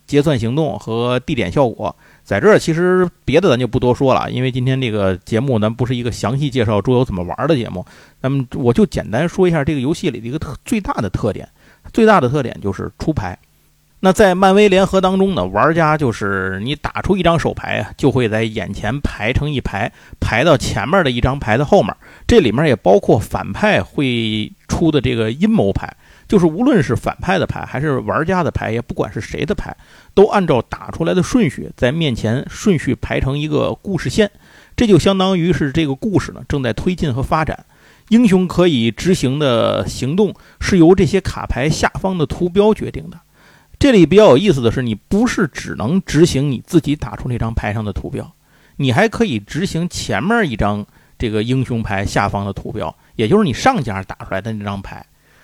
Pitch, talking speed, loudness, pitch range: 135 Hz, 305 characters per minute, -16 LUFS, 115-180 Hz